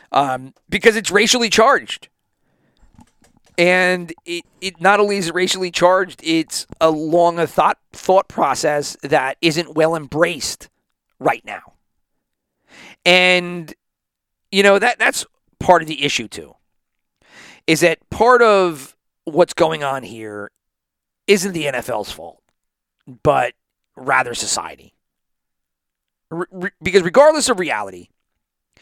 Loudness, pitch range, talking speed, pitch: -16 LUFS, 155-200 Hz, 120 wpm, 175 Hz